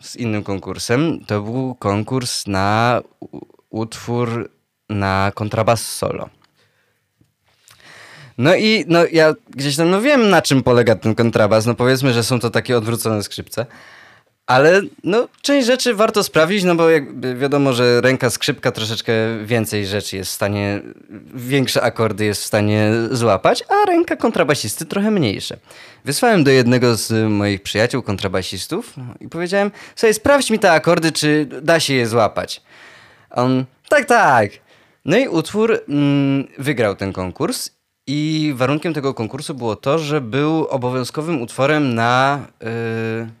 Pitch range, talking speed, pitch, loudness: 110-155 Hz, 145 wpm, 130 Hz, -17 LUFS